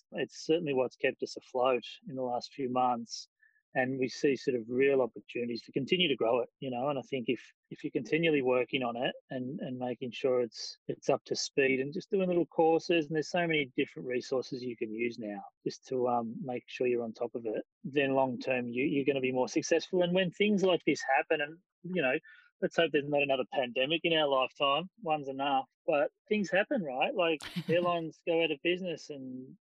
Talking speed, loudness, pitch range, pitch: 220 wpm, -32 LUFS, 130-175 Hz, 145 Hz